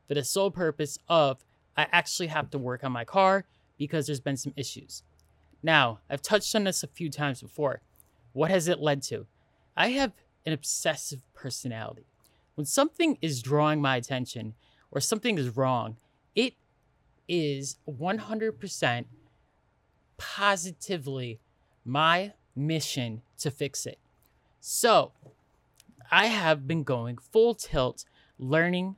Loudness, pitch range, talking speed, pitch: -28 LUFS, 130-175 Hz, 135 wpm, 145 Hz